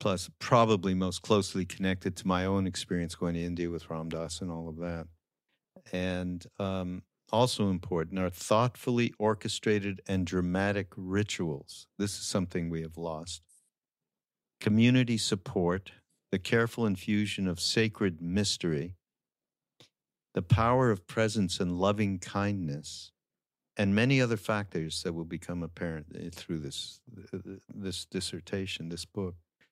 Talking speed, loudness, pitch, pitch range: 130 wpm, -31 LUFS, 95 Hz, 85-105 Hz